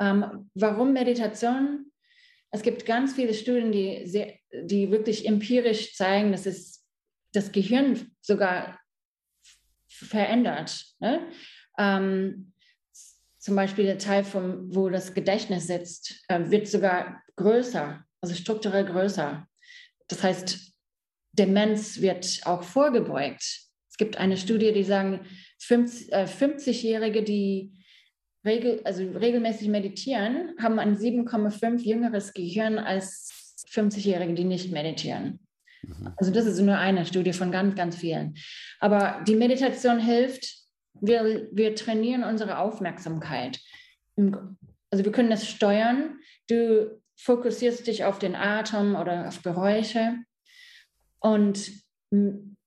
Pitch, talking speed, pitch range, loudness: 210 Hz, 115 wpm, 190-235 Hz, -26 LUFS